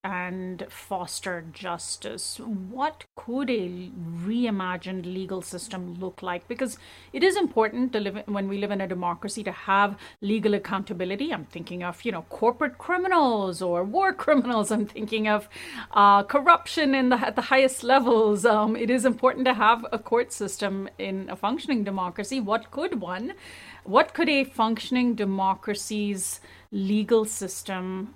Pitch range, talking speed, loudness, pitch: 190-245 Hz, 155 wpm, -25 LUFS, 210 Hz